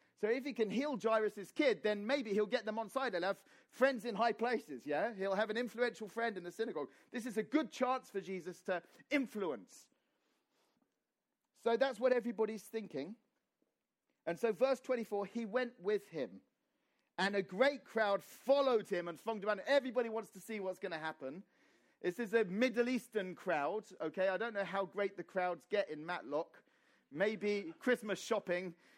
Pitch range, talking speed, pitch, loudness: 195-250 Hz, 180 wpm, 220 Hz, -38 LUFS